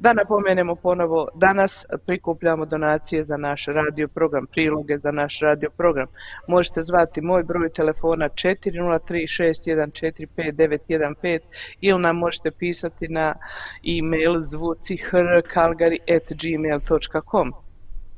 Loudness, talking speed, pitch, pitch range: -22 LUFS, 90 wpm, 165 Hz, 155-175 Hz